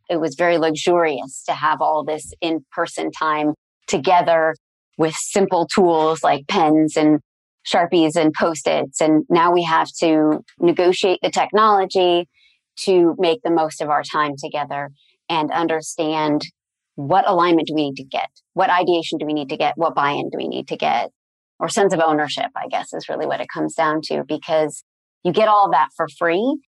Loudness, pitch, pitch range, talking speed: -19 LUFS, 160 Hz, 155-175 Hz, 180 wpm